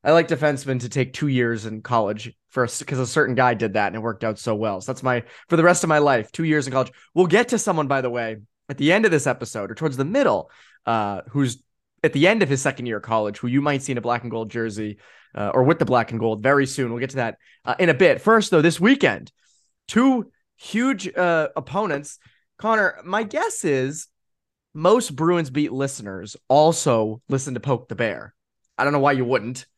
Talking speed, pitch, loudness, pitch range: 240 wpm, 135 Hz, -21 LUFS, 115-155 Hz